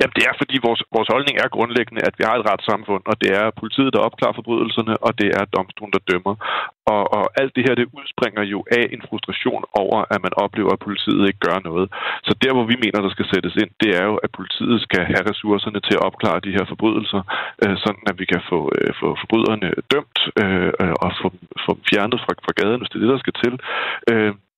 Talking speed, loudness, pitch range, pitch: 235 wpm, -19 LUFS, 100-115 Hz, 105 Hz